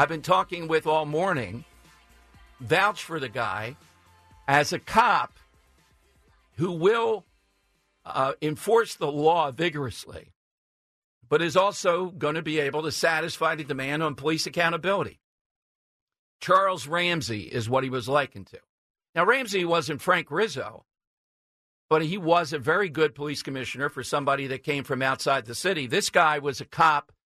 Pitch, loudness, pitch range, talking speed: 155 Hz, -25 LUFS, 135-170 Hz, 150 wpm